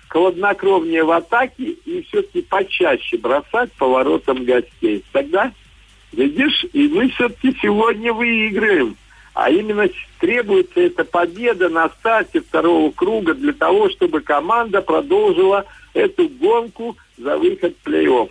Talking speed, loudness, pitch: 120 wpm, -17 LUFS, 245 Hz